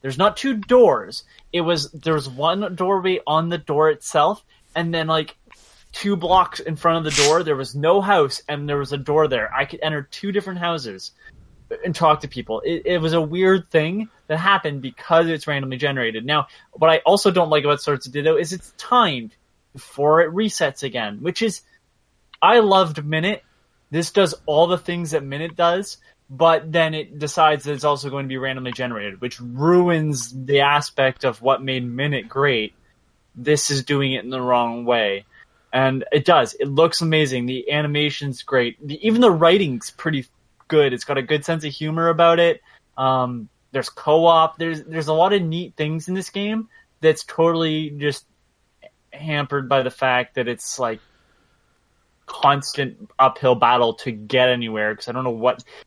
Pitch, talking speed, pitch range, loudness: 155 Hz, 185 wpm, 135-170 Hz, -20 LUFS